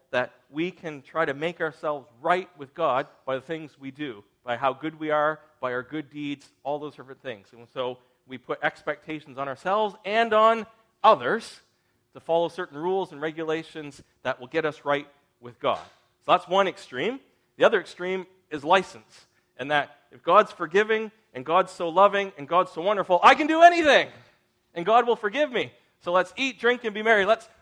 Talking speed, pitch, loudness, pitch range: 195 wpm, 160 Hz, -24 LUFS, 140-195 Hz